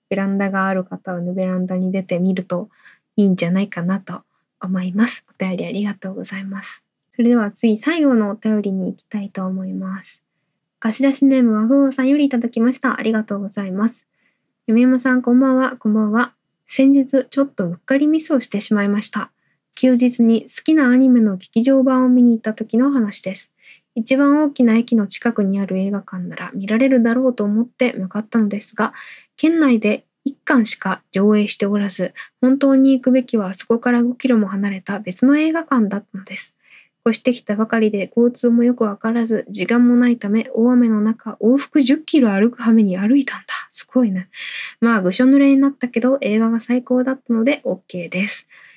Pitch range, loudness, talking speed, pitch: 200-255 Hz, -17 LUFS, 385 characters per minute, 225 Hz